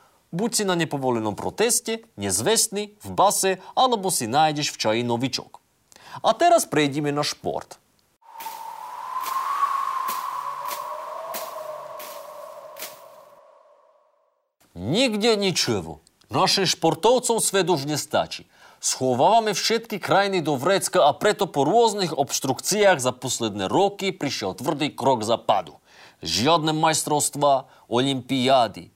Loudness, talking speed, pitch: -22 LUFS, 95 wpm, 180 Hz